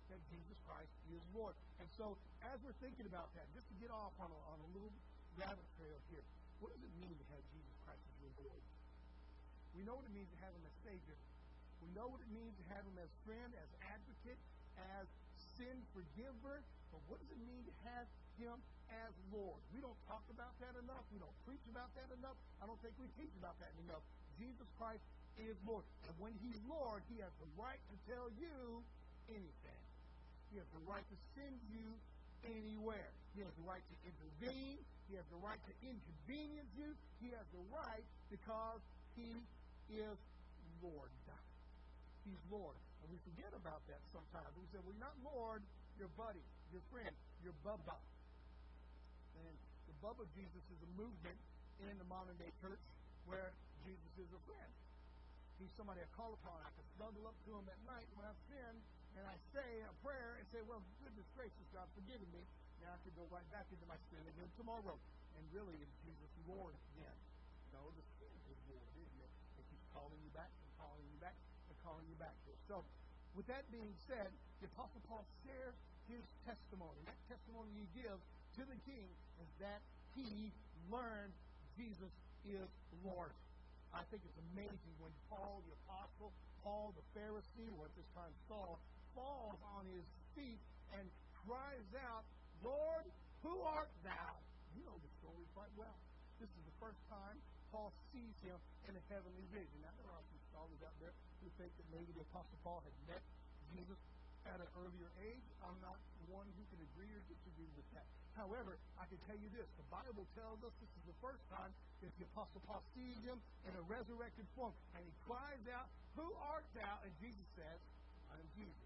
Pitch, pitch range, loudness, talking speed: 200 Hz, 155-230 Hz, -57 LUFS, 195 wpm